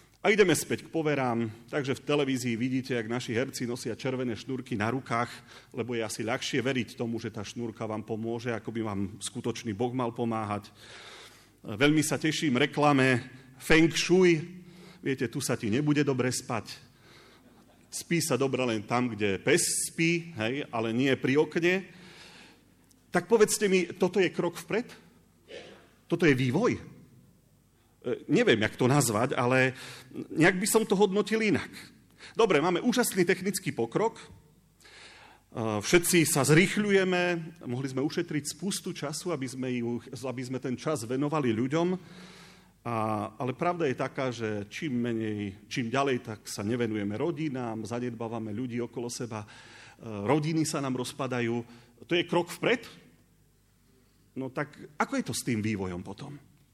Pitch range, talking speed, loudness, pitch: 115-160 Hz, 145 wpm, -29 LUFS, 130 Hz